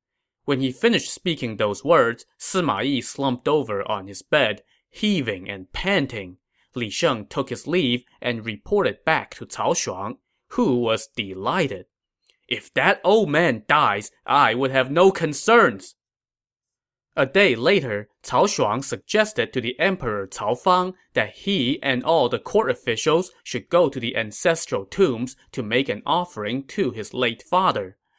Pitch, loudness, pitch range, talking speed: 130 Hz, -22 LUFS, 115-180 Hz, 155 wpm